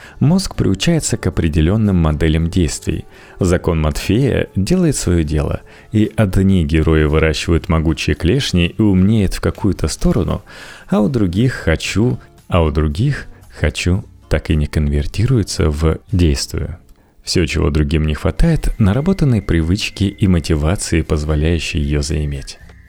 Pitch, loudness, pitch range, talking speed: 85 Hz, -16 LUFS, 80-100 Hz, 125 wpm